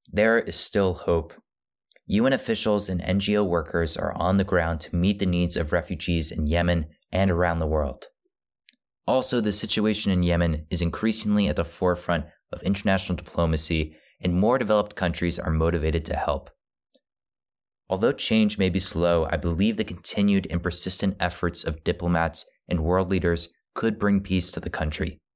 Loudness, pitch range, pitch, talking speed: -24 LUFS, 85-100 Hz, 90 Hz, 165 wpm